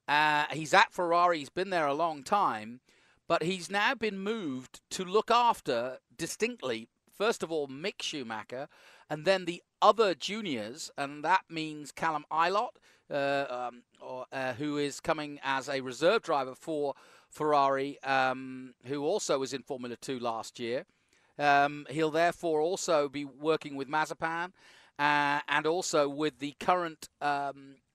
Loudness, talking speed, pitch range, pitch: -31 LUFS, 150 wpm, 140-170 Hz, 150 Hz